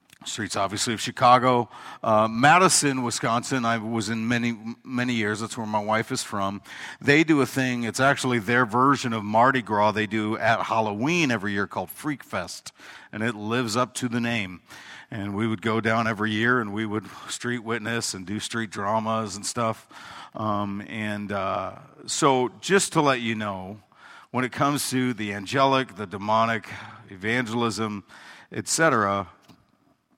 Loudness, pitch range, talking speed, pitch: -24 LUFS, 105-125 Hz, 165 wpm, 115 Hz